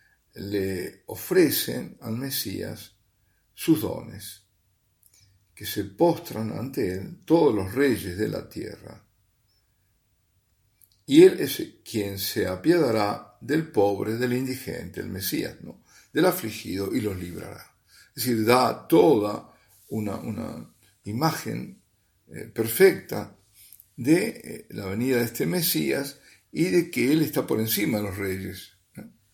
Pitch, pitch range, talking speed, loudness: 105 Hz, 100-130 Hz, 125 wpm, -25 LUFS